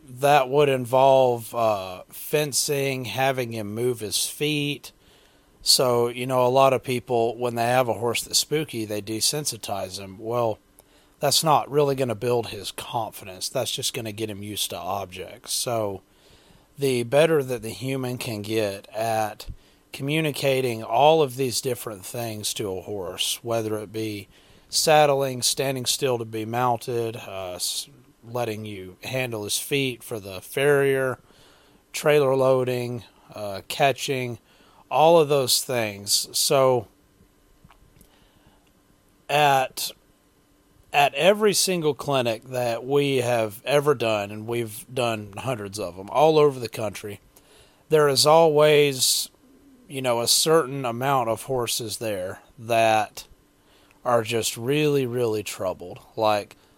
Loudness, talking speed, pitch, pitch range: -23 LUFS, 135 wpm, 120 Hz, 110-135 Hz